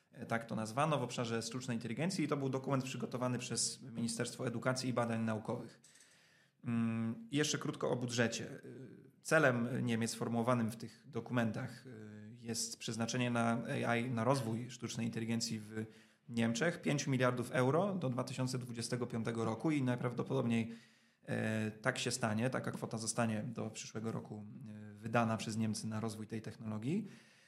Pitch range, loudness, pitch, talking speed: 115-130 Hz, -38 LUFS, 115 Hz, 135 wpm